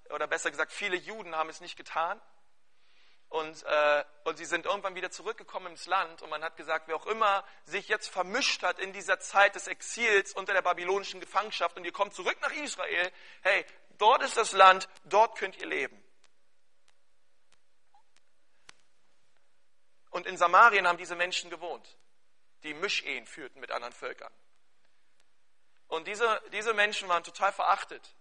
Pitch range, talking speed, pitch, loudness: 170-205 Hz, 155 wpm, 185 Hz, -29 LUFS